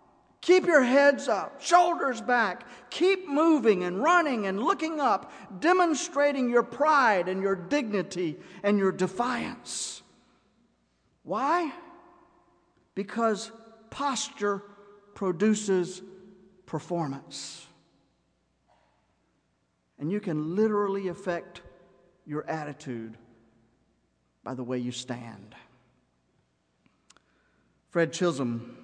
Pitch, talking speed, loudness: 195 Hz, 85 wpm, -27 LUFS